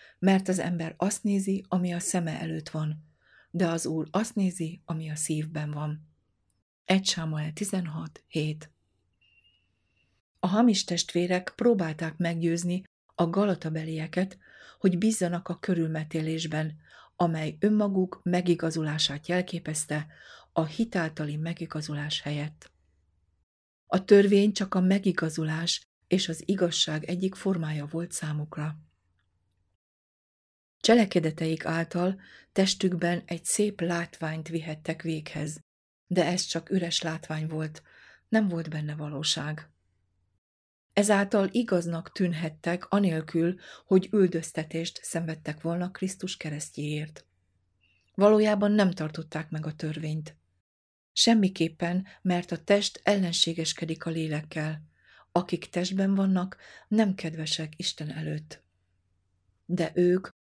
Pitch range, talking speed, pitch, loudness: 155-180 Hz, 100 wpm, 165 Hz, -28 LUFS